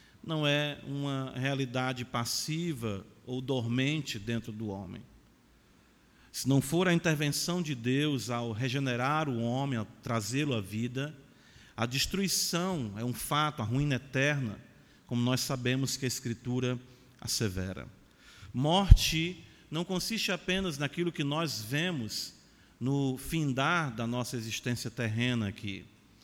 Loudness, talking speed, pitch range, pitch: -32 LUFS, 125 wpm, 115-150 Hz, 130 Hz